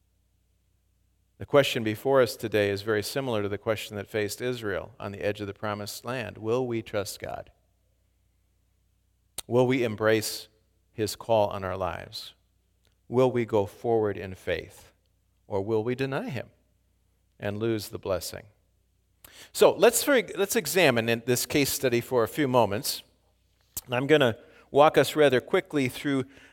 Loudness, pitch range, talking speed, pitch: -26 LUFS, 95-120 Hz, 155 wpm, 105 Hz